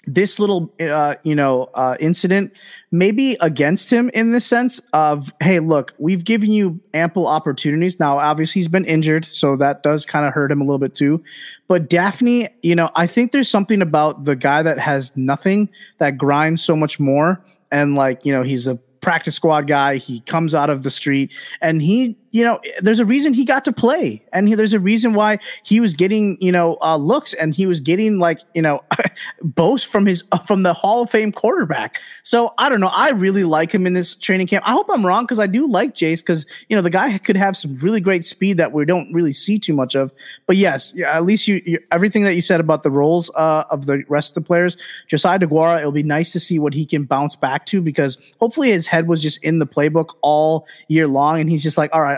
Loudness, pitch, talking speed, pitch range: -17 LUFS, 170 Hz, 235 wpm, 150-200 Hz